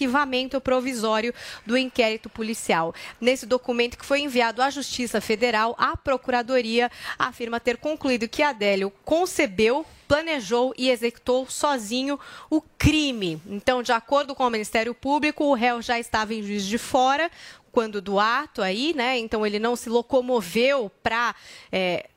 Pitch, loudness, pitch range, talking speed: 245 Hz, -24 LUFS, 225-270 Hz, 145 wpm